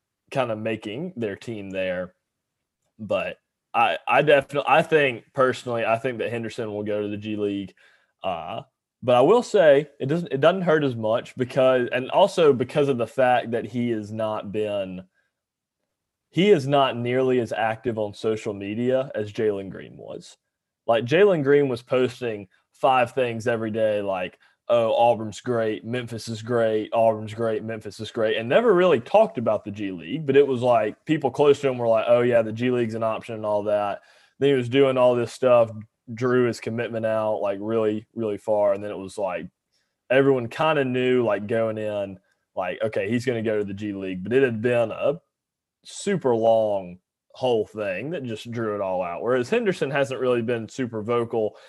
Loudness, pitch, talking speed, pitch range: -23 LUFS, 115 Hz, 195 wpm, 105-130 Hz